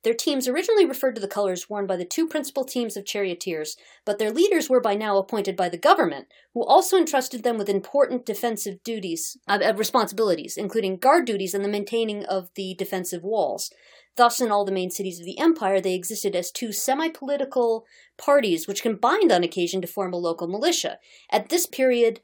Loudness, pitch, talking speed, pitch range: -23 LUFS, 220 Hz, 195 wpm, 195-265 Hz